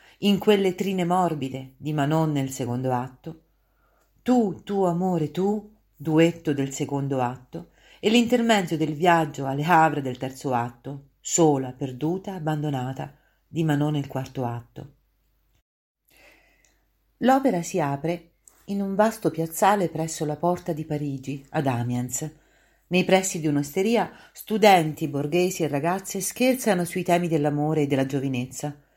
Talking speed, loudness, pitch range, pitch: 130 wpm, -24 LUFS, 140-185 Hz, 160 Hz